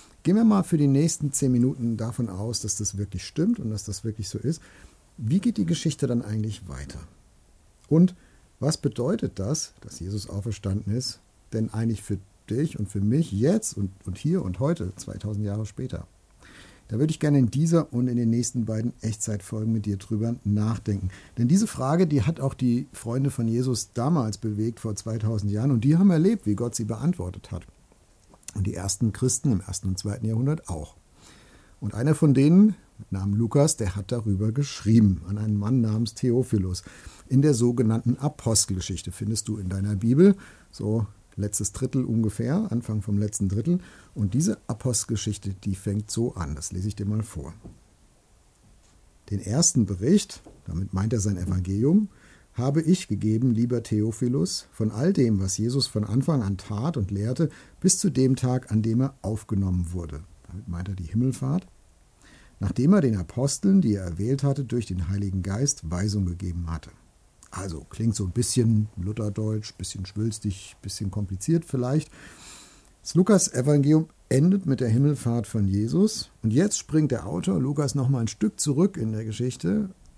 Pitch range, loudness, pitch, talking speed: 100-135 Hz, -25 LUFS, 110 Hz, 175 wpm